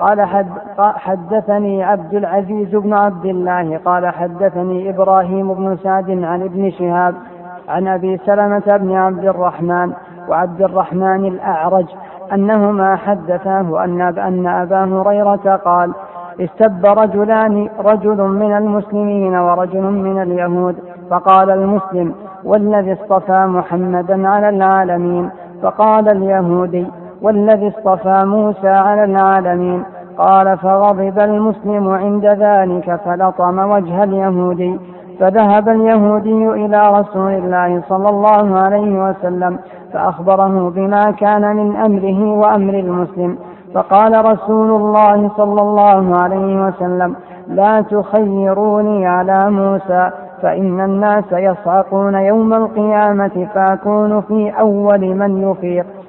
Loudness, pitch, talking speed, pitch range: -13 LUFS, 195 Hz, 105 wpm, 180-205 Hz